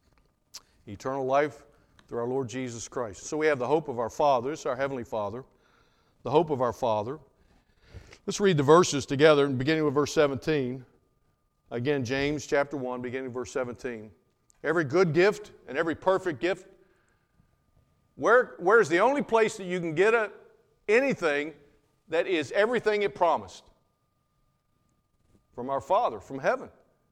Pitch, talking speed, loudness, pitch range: 145 Hz, 155 wpm, -27 LUFS, 130-190 Hz